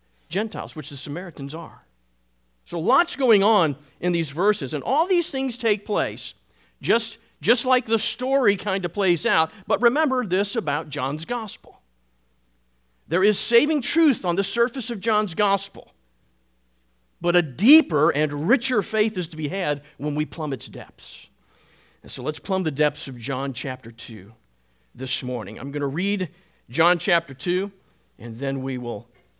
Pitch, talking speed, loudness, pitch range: 165 Hz, 165 wpm, -23 LUFS, 130-215 Hz